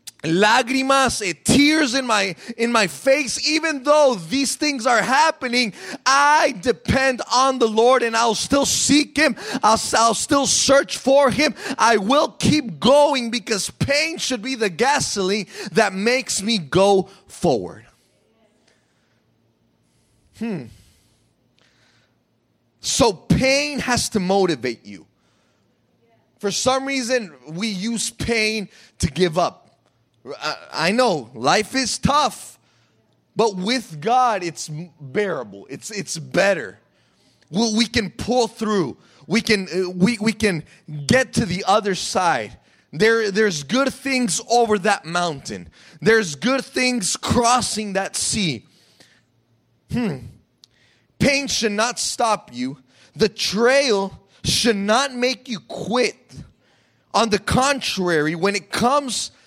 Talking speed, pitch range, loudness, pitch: 120 wpm, 180-255 Hz, -19 LUFS, 220 Hz